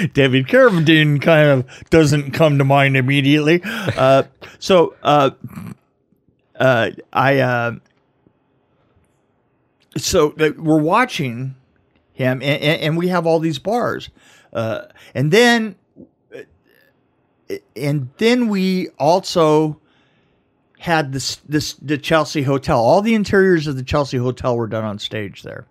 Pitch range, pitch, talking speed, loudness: 135-165 Hz, 150 Hz, 120 wpm, -16 LUFS